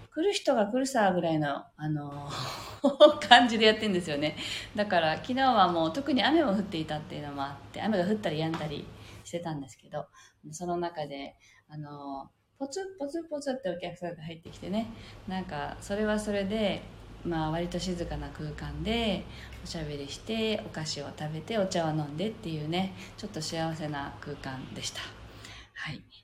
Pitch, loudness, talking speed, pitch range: 170 Hz, -30 LUFS, 350 characters per minute, 150-215 Hz